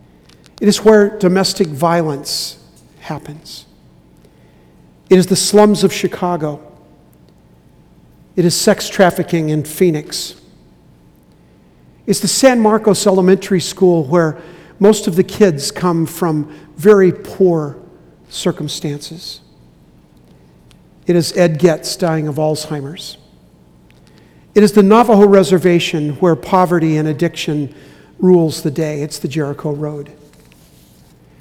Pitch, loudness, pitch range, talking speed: 165 Hz, -14 LUFS, 145-185 Hz, 110 wpm